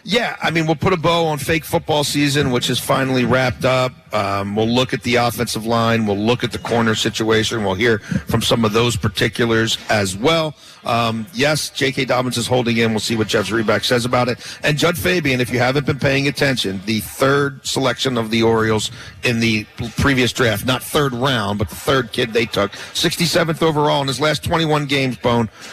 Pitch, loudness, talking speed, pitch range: 125 Hz, -18 LUFS, 210 wpm, 115-140 Hz